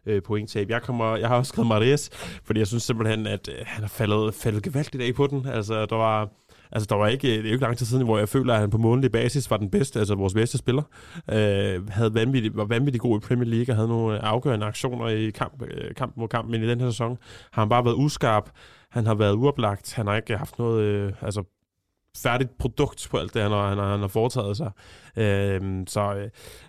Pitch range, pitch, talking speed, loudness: 105-120 Hz, 110 Hz, 240 wpm, -25 LUFS